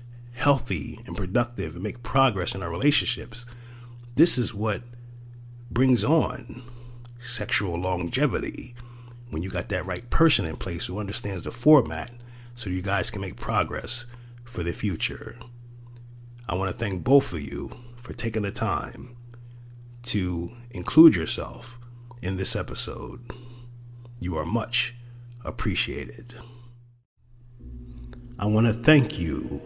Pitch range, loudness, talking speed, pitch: 100-120 Hz, -25 LUFS, 125 wpm, 120 Hz